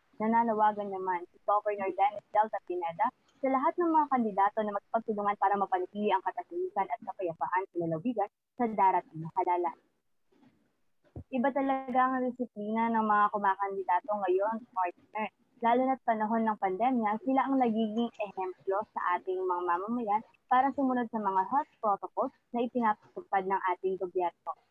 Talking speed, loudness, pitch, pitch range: 145 wpm, -31 LUFS, 210 Hz, 190-240 Hz